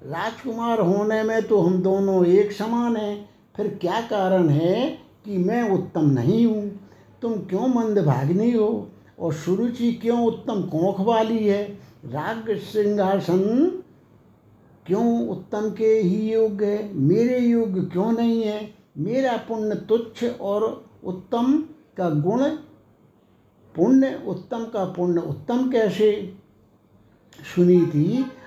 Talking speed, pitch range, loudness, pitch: 120 wpm, 185-230 Hz, -22 LUFS, 210 Hz